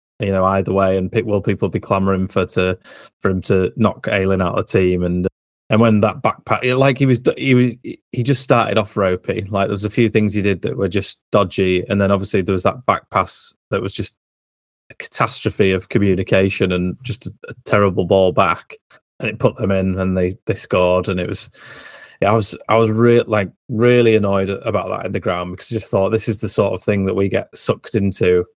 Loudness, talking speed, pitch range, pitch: -17 LUFS, 235 wpm, 95-110 Hz, 100 Hz